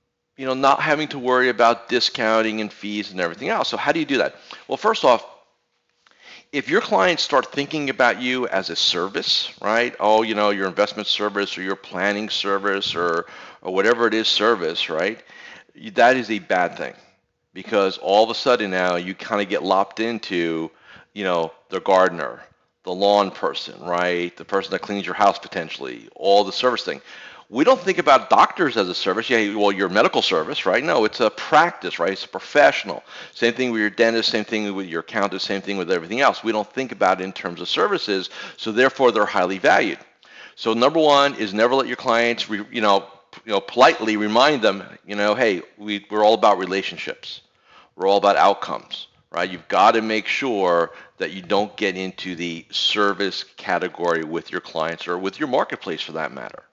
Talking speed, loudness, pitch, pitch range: 200 wpm, -20 LUFS, 105 Hz, 95-115 Hz